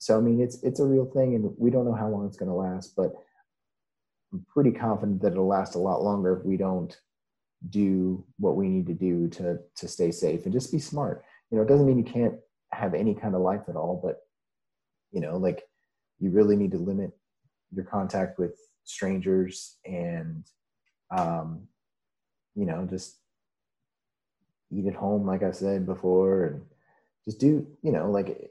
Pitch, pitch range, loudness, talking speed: 100 Hz, 95-130 Hz, -27 LUFS, 190 wpm